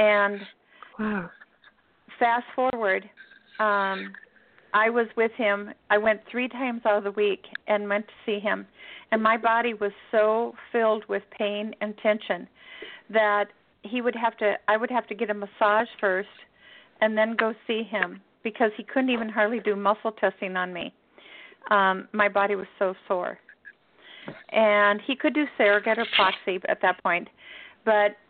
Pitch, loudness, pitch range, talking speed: 215 Hz, -25 LUFS, 205-230 Hz, 160 wpm